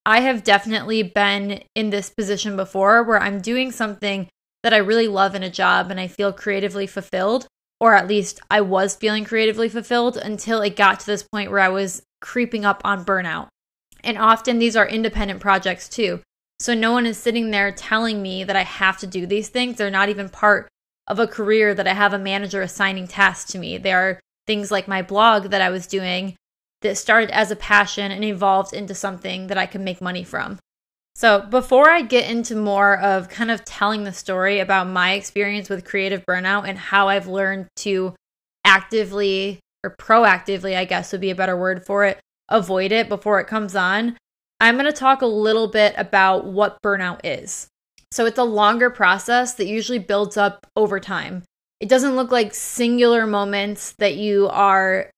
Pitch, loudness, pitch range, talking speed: 200 Hz, -19 LUFS, 195-220 Hz, 195 wpm